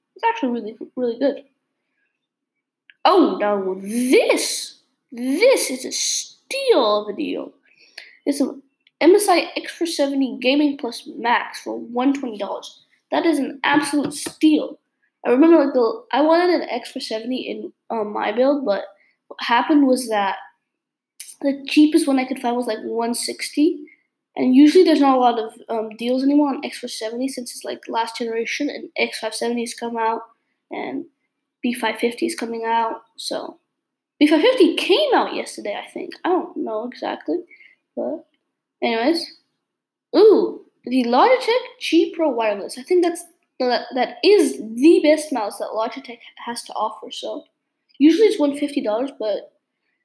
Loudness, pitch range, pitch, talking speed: -20 LUFS, 240-325 Hz, 285 Hz, 150 wpm